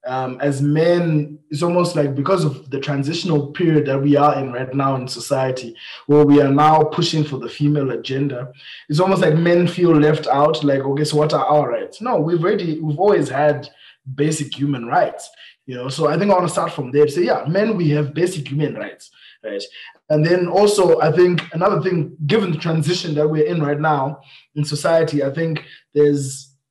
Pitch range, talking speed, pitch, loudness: 140-170 Hz, 205 wpm, 150 Hz, -18 LUFS